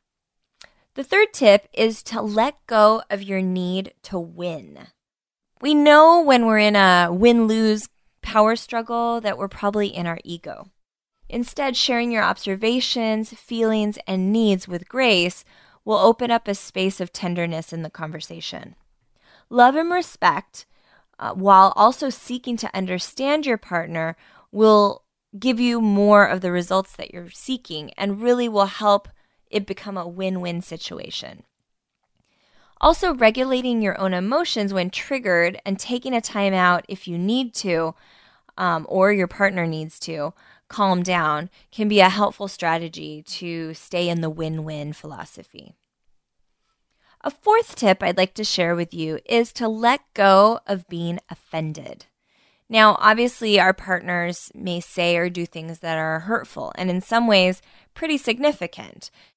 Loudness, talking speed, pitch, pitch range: -20 LUFS, 150 wpm, 200 Hz, 175-230 Hz